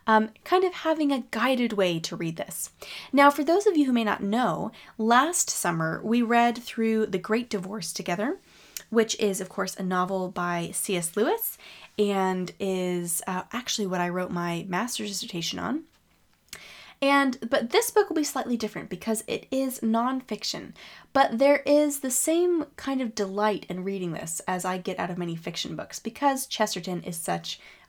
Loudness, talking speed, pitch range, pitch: -26 LUFS, 180 wpm, 185-265 Hz, 220 Hz